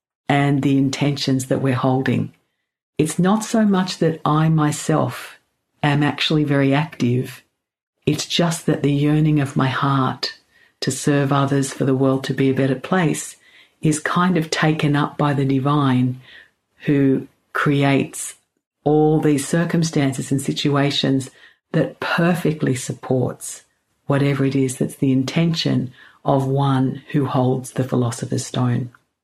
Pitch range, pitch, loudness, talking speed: 135-150 Hz, 140 Hz, -19 LUFS, 140 wpm